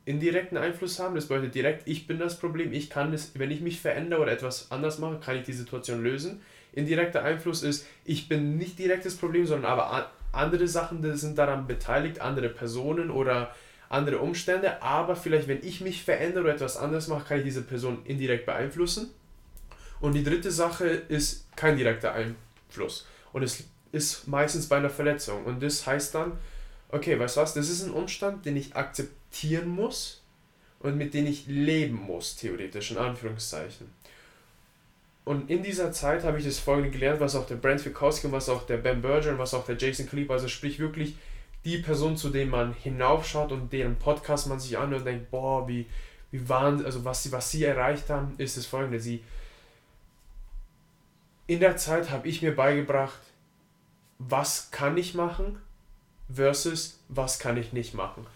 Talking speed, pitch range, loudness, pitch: 185 wpm, 130-160 Hz, -29 LUFS, 145 Hz